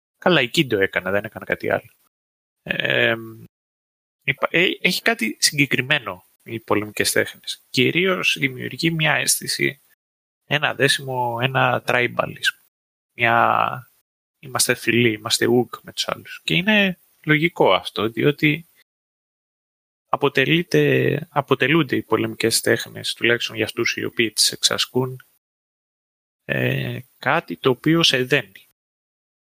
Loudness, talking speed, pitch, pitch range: -20 LUFS, 110 wpm, 130 Hz, 110-155 Hz